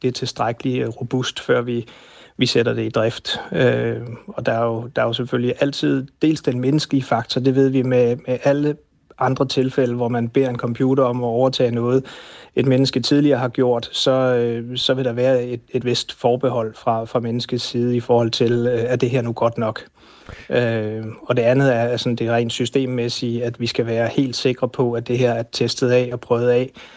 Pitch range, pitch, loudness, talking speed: 120-130 Hz, 125 Hz, -20 LUFS, 215 wpm